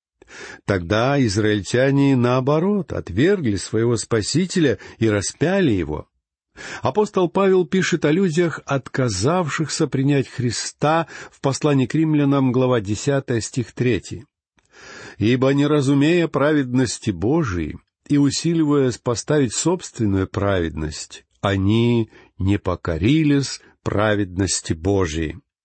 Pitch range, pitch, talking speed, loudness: 105-150 Hz, 130 Hz, 95 wpm, -20 LUFS